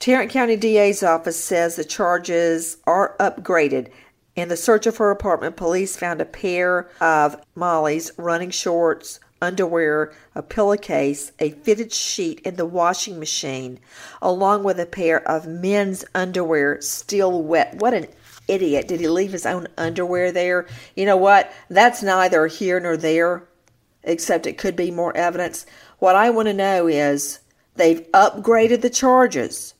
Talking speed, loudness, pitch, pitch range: 155 wpm, -19 LUFS, 175 Hz, 165-195 Hz